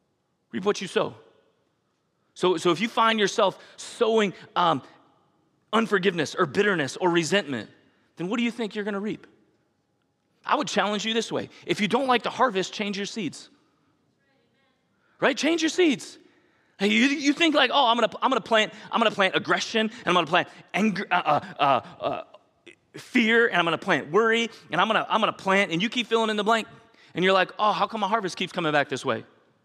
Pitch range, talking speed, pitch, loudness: 180-230 Hz, 210 wpm, 205 Hz, -24 LUFS